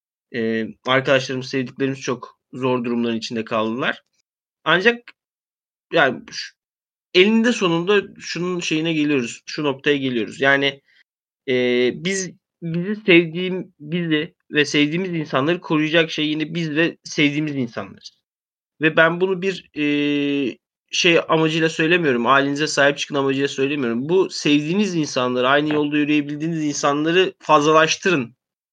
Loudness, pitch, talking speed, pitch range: -19 LUFS, 150 Hz, 115 wpm, 135-170 Hz